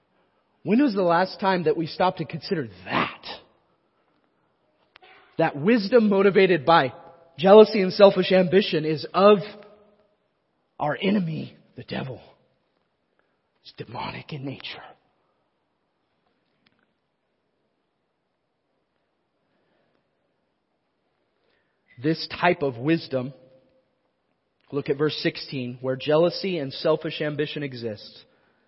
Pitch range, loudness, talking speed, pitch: 145-195 Hz, -22 LUFS, 90 wpm, 165 Hz